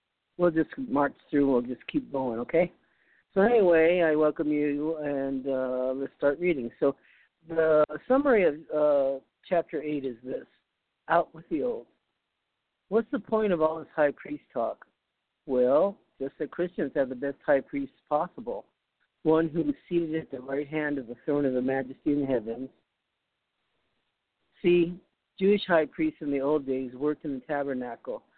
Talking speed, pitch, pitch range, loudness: 165 wpm, 150 Hz, 135-170 Hz, -28 LUFS